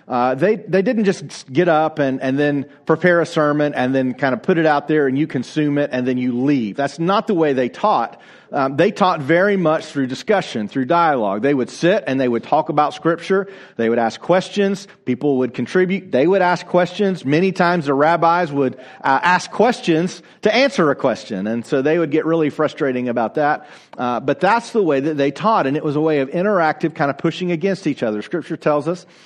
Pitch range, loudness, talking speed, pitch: 135-180 Hz, -18 LUFS, 225 wpm, 155 Hz